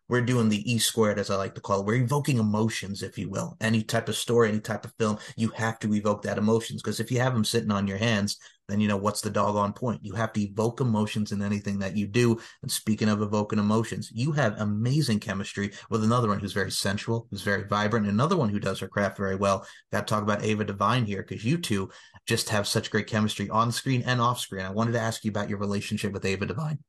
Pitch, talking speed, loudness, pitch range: 105 Hz, 255 wpm, -27 LUFS, 100-115 Hz